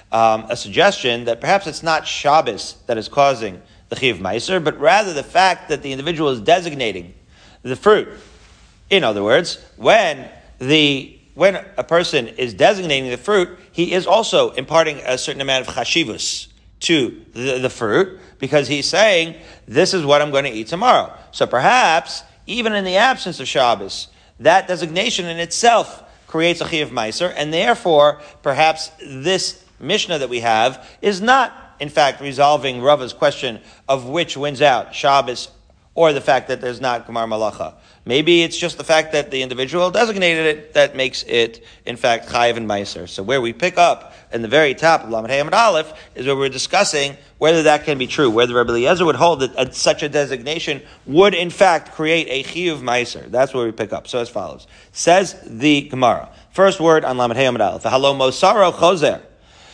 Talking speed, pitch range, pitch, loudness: 180 wpm, 125-170 Hz, 145 Hz, -17 LUFS